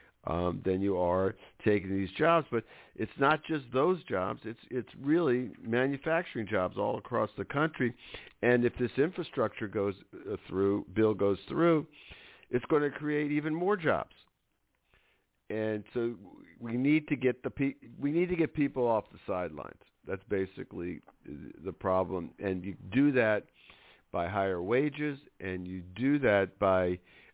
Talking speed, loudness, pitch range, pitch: 155 wpm, -31 LUFS, 95-145 Hz, 120 Hz